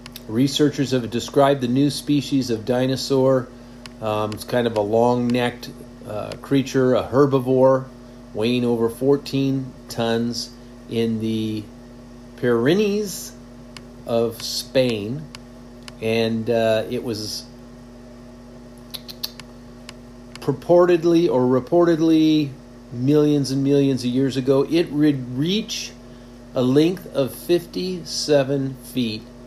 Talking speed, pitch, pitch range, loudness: 100 wpm, 125 Hz, 120-135 Hz, -21 LUFS